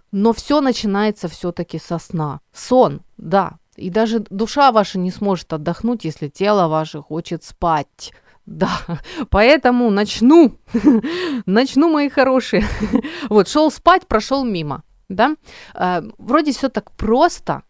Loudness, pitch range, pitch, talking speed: -17 LUFS, 175-260 Hz, 215 Hz, 120 wpm